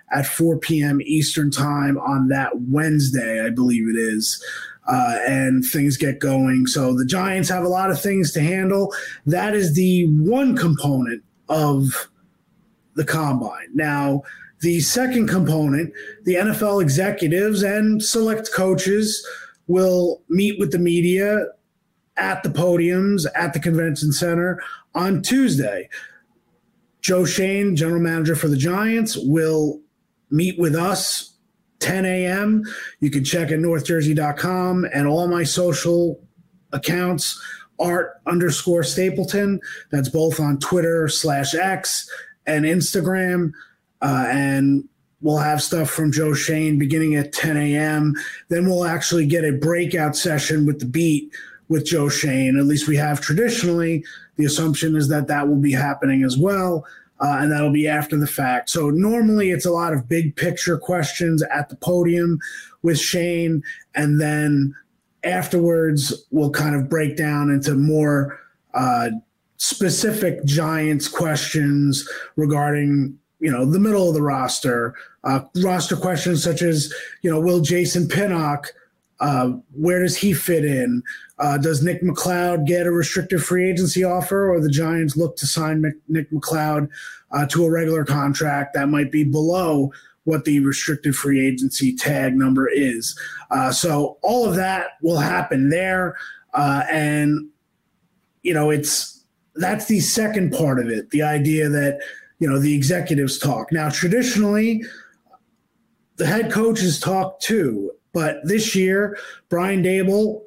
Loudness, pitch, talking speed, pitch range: -20 LUFS, 160 Hz, 145 wpm, 145-180 Hz